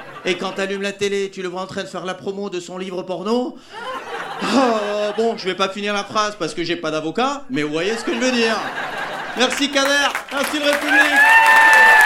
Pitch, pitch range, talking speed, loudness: 210 Hz, 185-270 Hz, 220 wpm, -18 LUFS